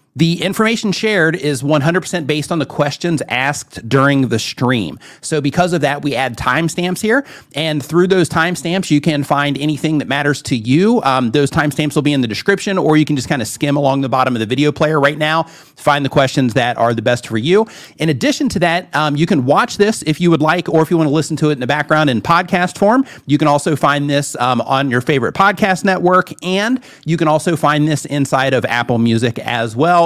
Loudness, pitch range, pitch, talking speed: -15 LUFS, 140-170 Hz, 150 Hz, 230 wpm